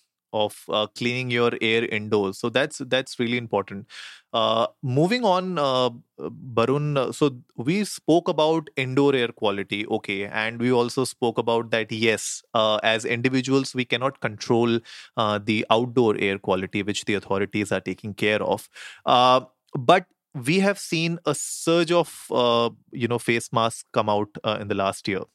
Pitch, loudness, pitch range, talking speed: 120 Hz, -23 LUFS, 105-135 Hz, 165 wpm